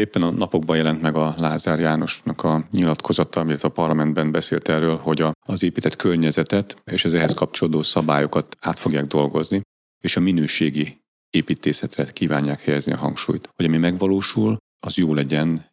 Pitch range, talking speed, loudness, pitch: 75-85 Hz, 155 wpm, -21 LUFS, 80 Hz